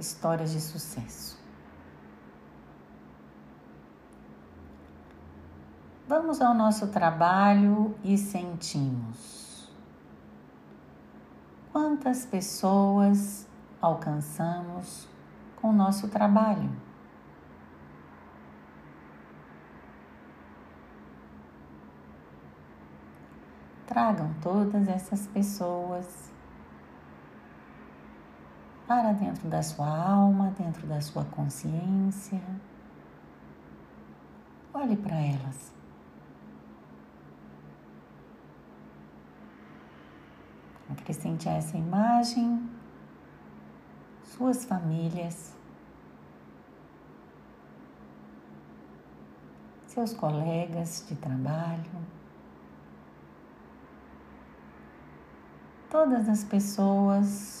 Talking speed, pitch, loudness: 45 wpm, 155 Hz, -28 LUFS